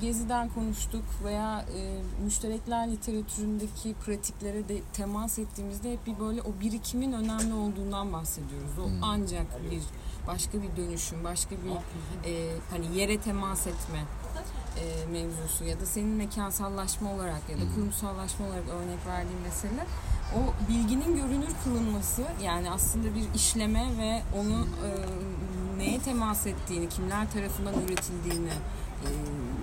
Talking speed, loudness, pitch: 130 wpm, -32 LUFS, 195 Hz